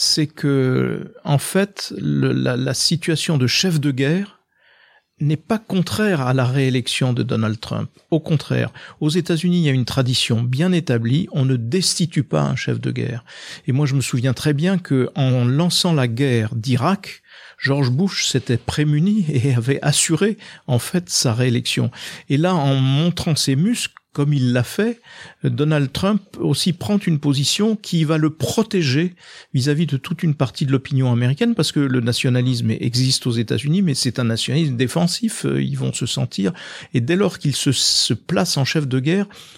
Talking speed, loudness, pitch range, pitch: 180 wpm, -19 LUFS, 125-170 Hz, 145 Hz